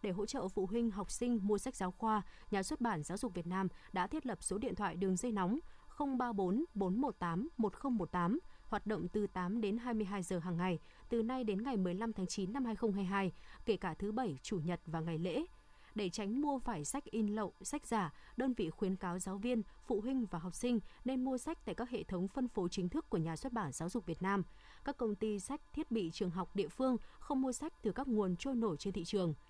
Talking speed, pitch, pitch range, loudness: 240 wpm, 210 Hz, 185-245 Hz, -39 LUFS